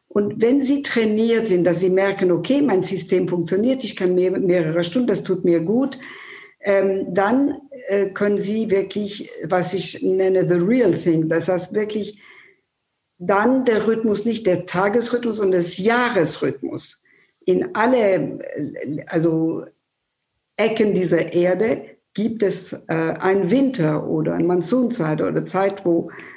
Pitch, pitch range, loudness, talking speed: 195 Hz, 180-225 Hz, -20 LUFS, 135 wpm